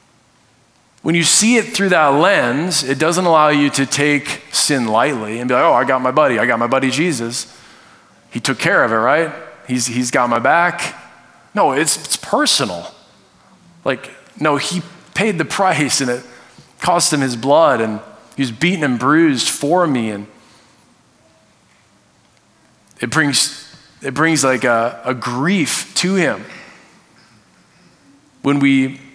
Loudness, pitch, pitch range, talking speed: -15 LUFS, 140 Hz, 125-165 Hz, 155 wpm